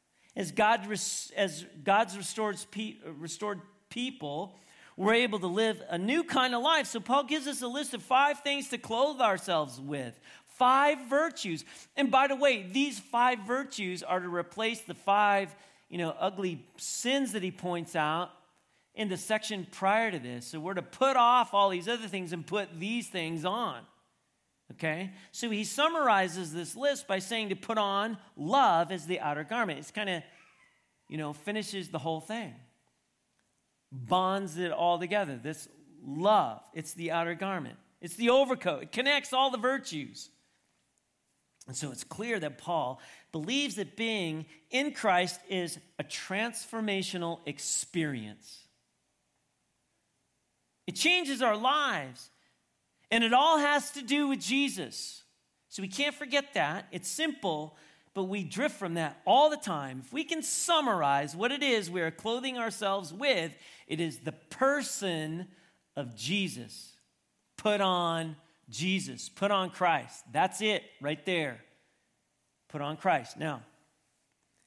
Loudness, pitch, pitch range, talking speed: -30 LUFS, 195 Hz, 165-240 Hz, 150 wpm